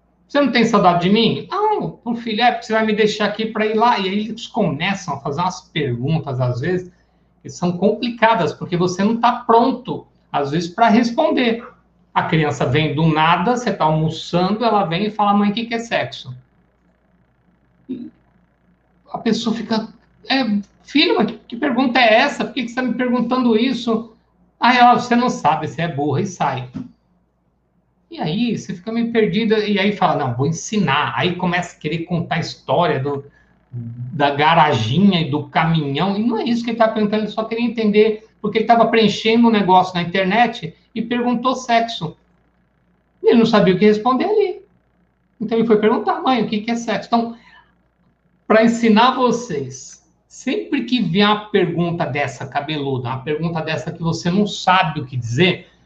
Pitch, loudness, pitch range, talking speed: 210 Hz, -18 LUFS, 165-230 Hz, 185 wpm